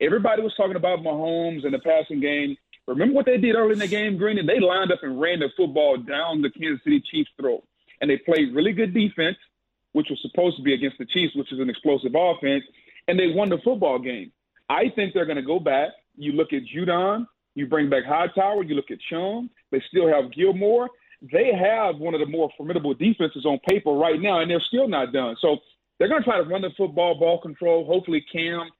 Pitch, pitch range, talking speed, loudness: 175 Hz, 155-215 Hz, 230 wpm, -23 LUFS